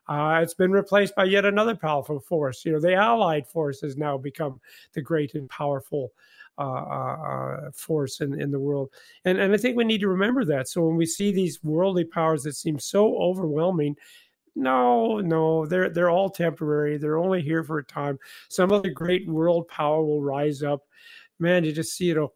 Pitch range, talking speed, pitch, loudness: 150-185 Hz, 200 wpm, 160 Hz, -24 LUFS